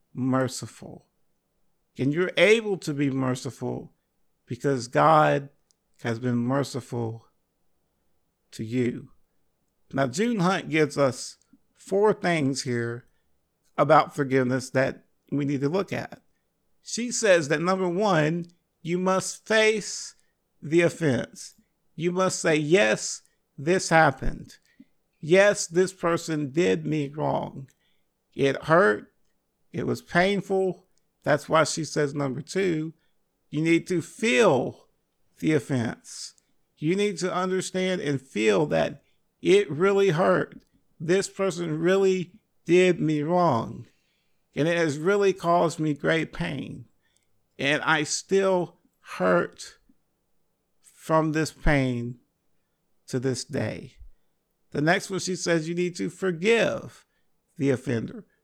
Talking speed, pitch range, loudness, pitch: 115 wpm, 135-185 Hz, -25 LUFS, 160 Hz